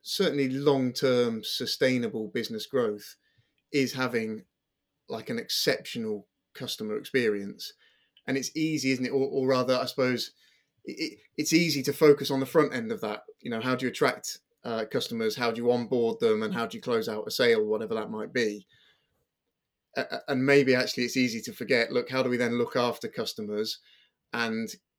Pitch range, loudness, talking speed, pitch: 120-155 Hz, -28 LUFS, 185 wpm, 130 Hz